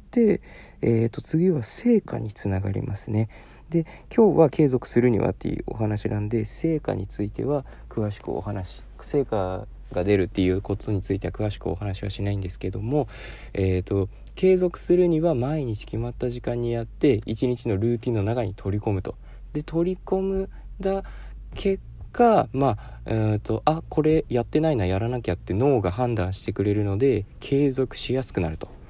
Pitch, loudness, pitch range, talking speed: 115 Hz, -25 LUFS, 100-145 Hz, 310 characters per minute